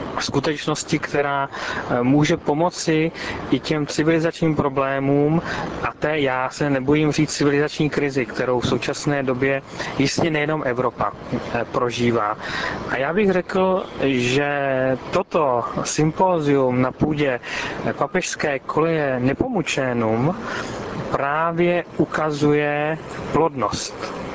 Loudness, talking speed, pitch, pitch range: -21 LUFS, 95 wpm, 145 Hz, 135-160 Hz